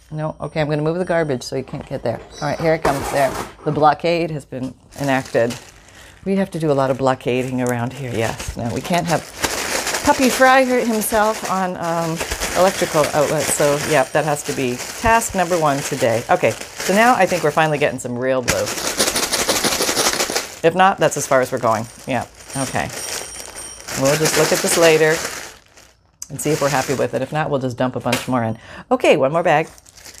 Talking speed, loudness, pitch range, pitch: 205 wpm, -18 LUFS, 125-170 Hz, 145 Hz